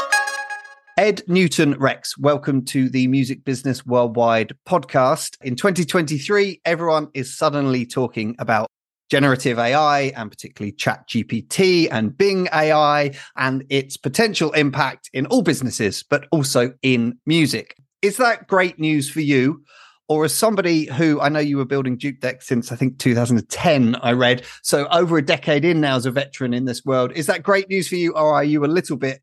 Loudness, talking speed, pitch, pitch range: -19 LUFS, 170 wpm, 145 Hz, 130-165 Hz